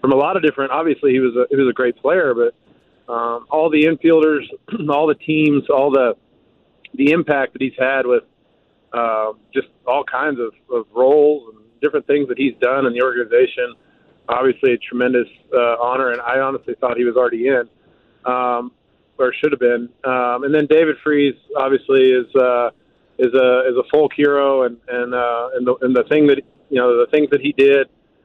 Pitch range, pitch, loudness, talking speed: 125-150 Hz, 130 Hz, -17 LUFS, 205 wpm